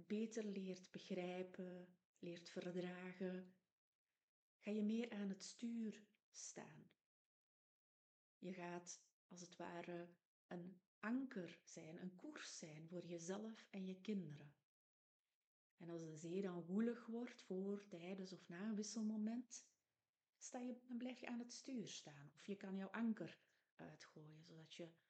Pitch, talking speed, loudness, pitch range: 185 Hz, 140 wpm, -51 LUFS, 175-215 Hz